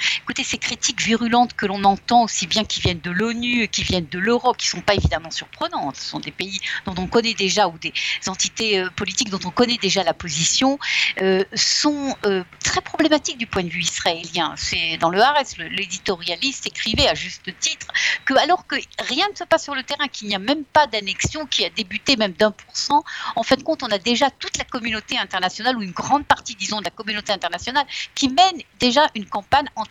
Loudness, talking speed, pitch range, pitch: -20 LUFS, 225 wpm, 195-275 Hz, 225 Hz